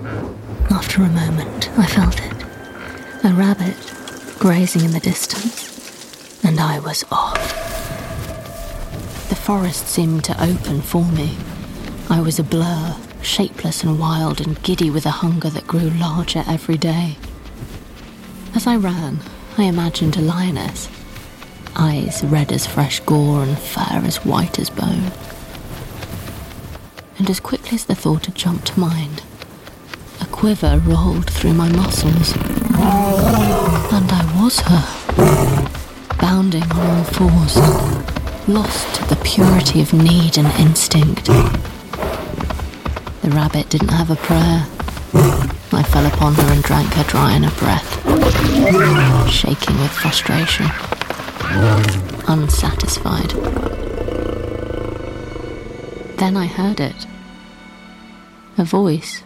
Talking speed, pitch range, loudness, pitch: 115 wpm, 145-185 Hz, -17 LUFS, 165 Hz